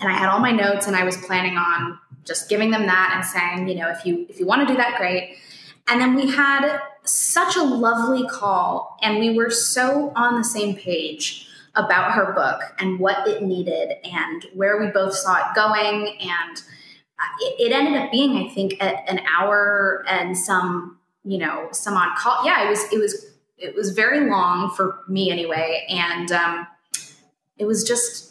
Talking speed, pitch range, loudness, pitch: 195 wpm, 180-240 Hz, -20 LUFS, 200 Hz